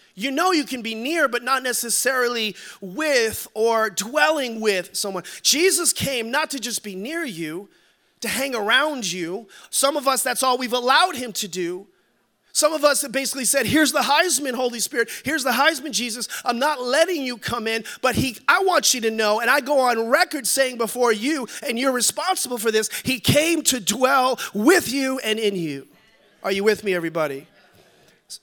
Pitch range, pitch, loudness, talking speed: 220-290 Hz, 250 Hz, -21 LUFS, 190 wpm